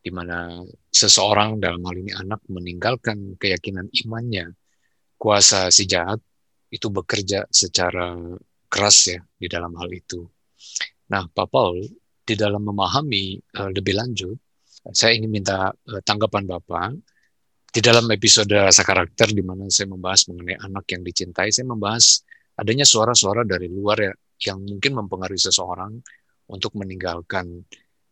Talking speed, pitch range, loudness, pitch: 130 wpm, 90-110 Hz, -18 LUFS, 100 Hz